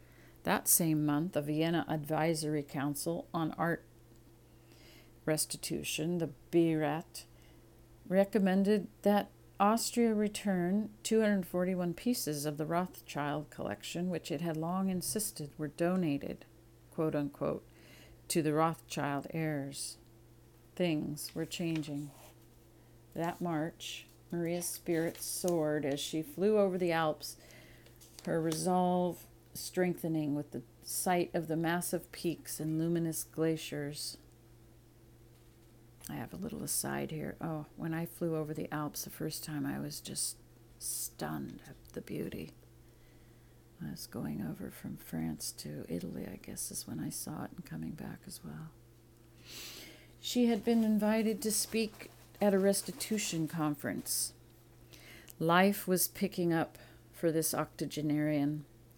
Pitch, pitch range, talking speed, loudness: 150 Hz, 115-170 Hz, 125 wpm, -35 LUFS